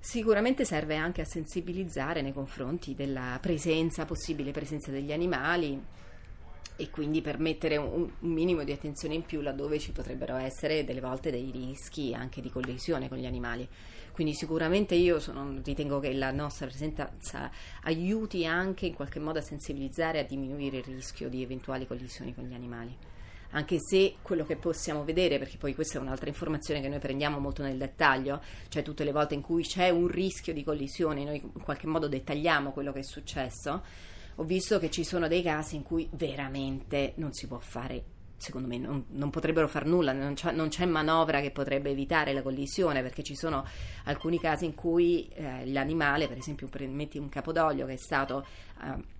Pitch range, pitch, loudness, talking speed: 135-165 Hz, 150 Hz, -32 LUFS, 185 wpm